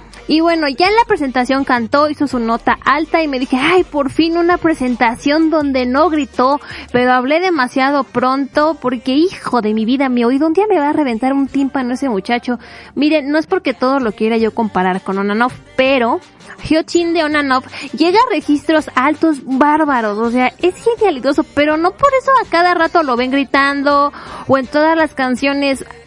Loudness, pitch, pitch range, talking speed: -14 LUFS, 280 Hz, 255-315 Hz, 190 wpm